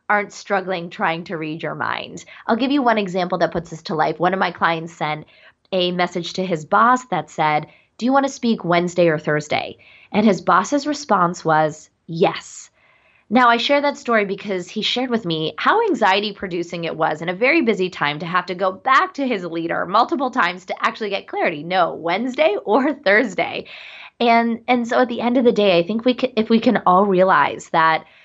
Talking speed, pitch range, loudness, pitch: 210 wpm, 170-235 Hz, -19 LUFS, 190 Hz